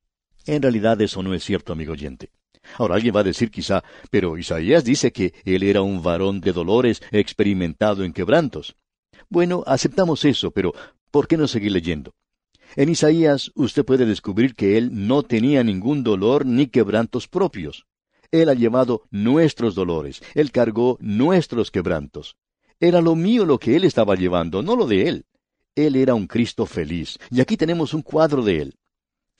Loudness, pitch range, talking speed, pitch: -20 LUFS, 95-145 Hz, 170 wpm, 115 Hz